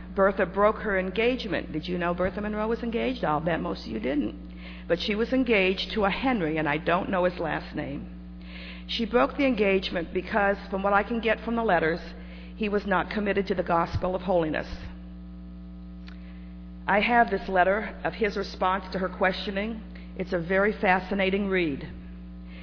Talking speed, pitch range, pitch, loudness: 180 wpm, 155-205 Hz, 185 Hz, -26 LUFS